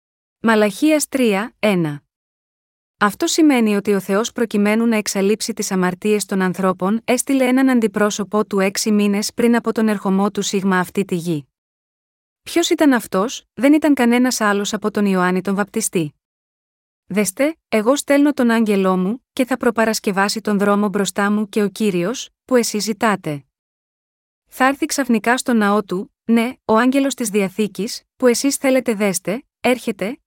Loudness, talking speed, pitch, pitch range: -18 LUFS, 155 wpm, 215 Hz, 200-245 Hz